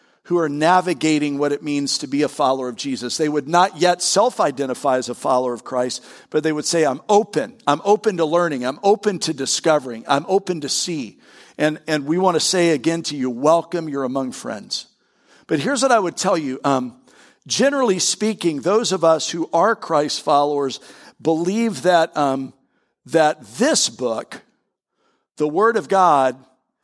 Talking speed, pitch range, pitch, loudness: 180 wpm, 140-175 Hz, 155 Hz, -19 LUFS